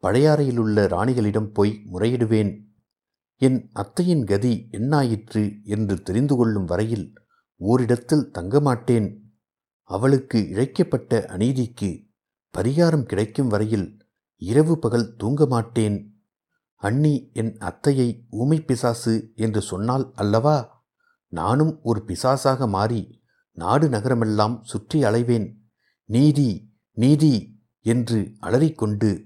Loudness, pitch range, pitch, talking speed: -22 LUFS, 105-130 Hz, 115 Hz, 90 wpm